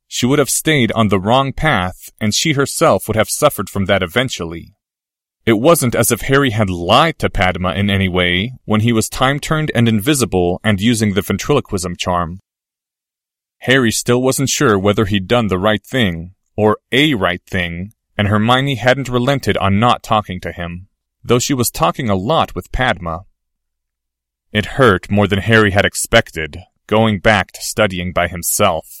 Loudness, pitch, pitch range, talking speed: -15 LUFS, 105 Hz, 90-120 Hz, 175 wpm